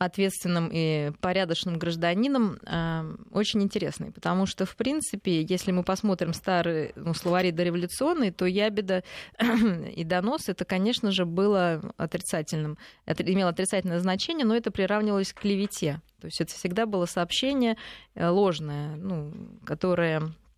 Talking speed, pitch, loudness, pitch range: 130 wpm, 185 Hz, -27 LUFS, 170-205 Hz